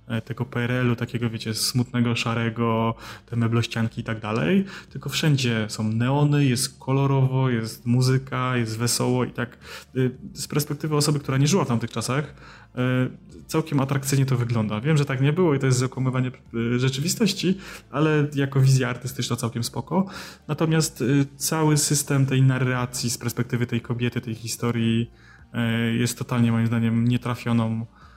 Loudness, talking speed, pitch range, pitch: -24 LUFS, 145 wpm, 115-140 Hz, 125 Hz